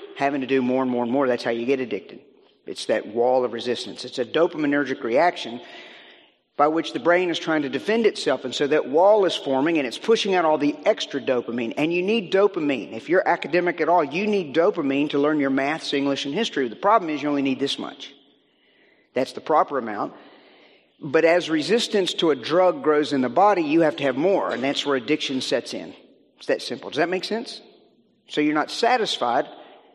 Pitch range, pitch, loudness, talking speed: 135-180 Hz, 150 Hz, -22 LUFS, 220 wpm